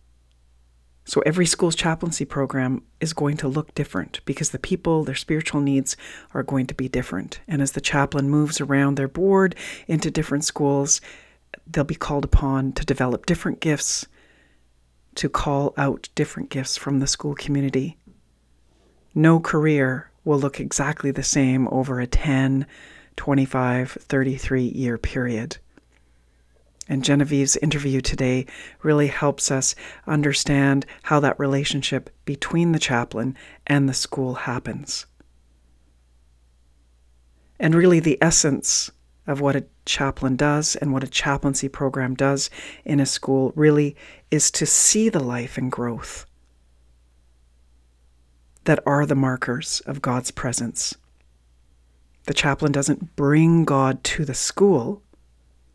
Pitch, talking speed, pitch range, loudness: 135 Hz, 130 wpm, 110-145 Hz, -22 LUFS